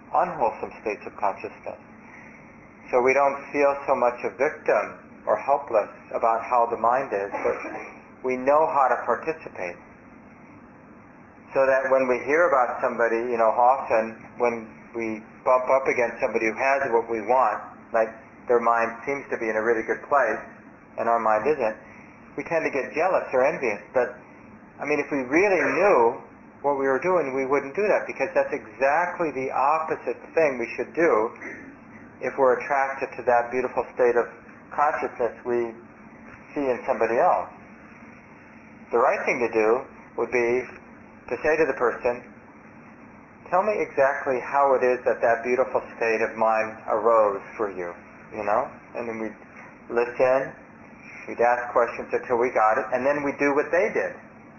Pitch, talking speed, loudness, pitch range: 125 Hz, 170 wpm, -24 LUFS, 115-135 Hz